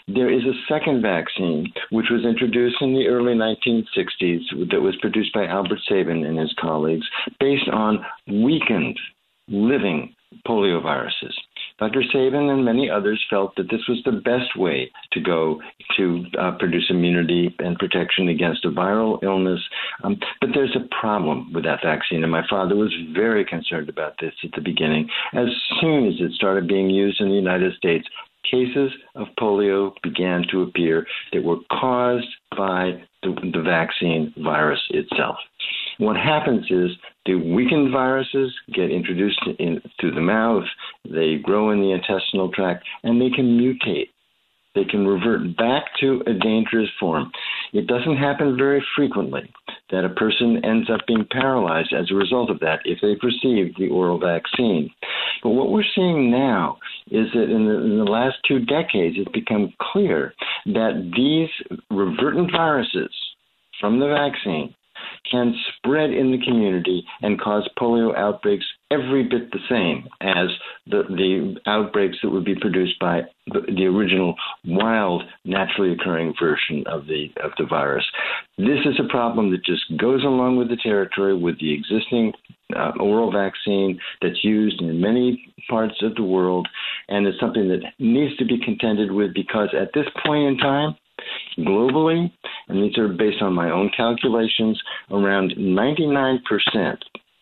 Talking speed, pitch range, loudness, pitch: 160 wpm, 95-125 Hz, -21 LUFS, 110 Hz